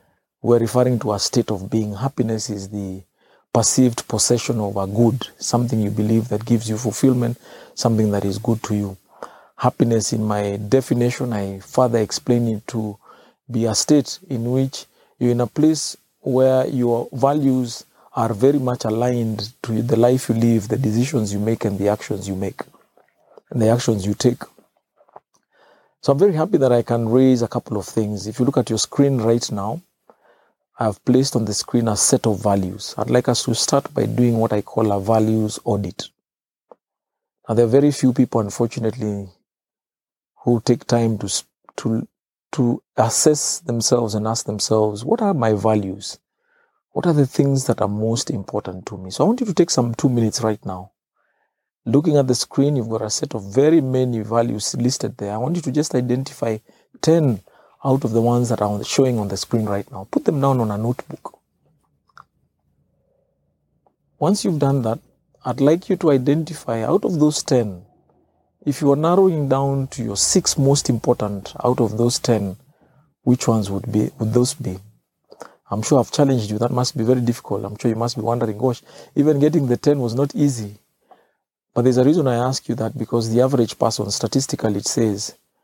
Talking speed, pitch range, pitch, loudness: 190 wpm, 110-135 Hz, 120 Hz, -19 LUFS